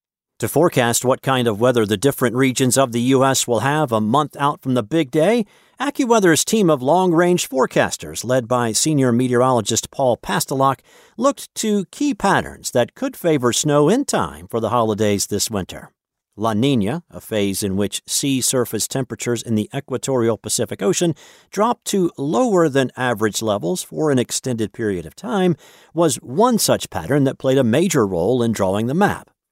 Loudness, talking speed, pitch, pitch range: -18 LUFS, 175 wpm, 130 Hz, 115-170 Hz